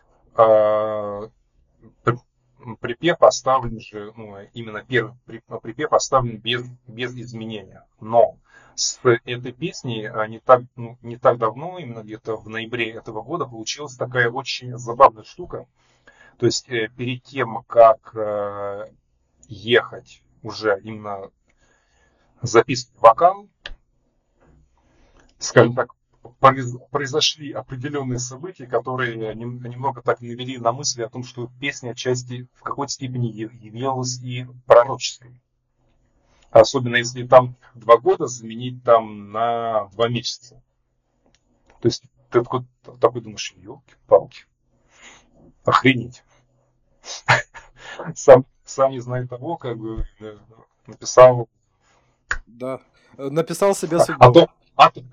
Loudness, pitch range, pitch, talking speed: -19 LUFS, 115-130 Hz, 120 Hz, 110 wpm